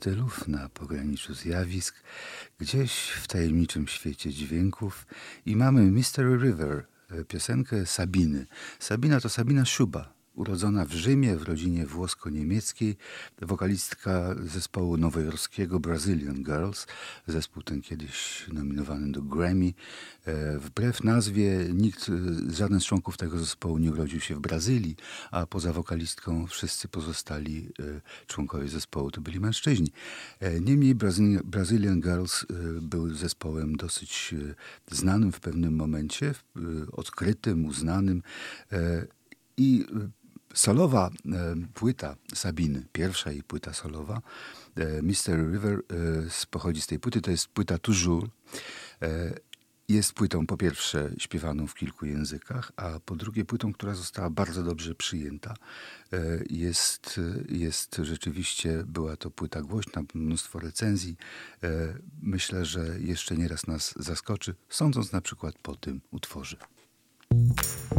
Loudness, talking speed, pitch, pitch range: -29 LUFS, 115 wpm, 85 Hz, 80-100 Hz